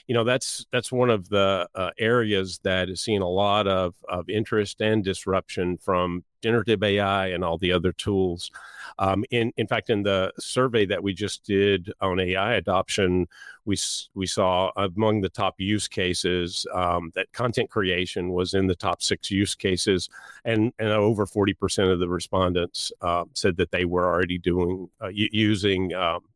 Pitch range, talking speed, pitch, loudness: 90-105 Hz, 180 wpm, 95 Hz, -24 LUFS